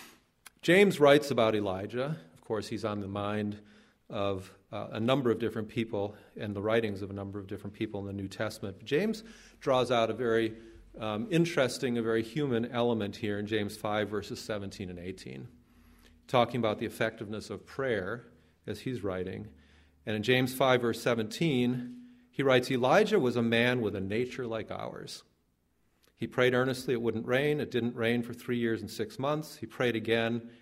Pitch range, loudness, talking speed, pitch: 105-125 Hz, -31 LUFS, 180 wpm, 115 Hz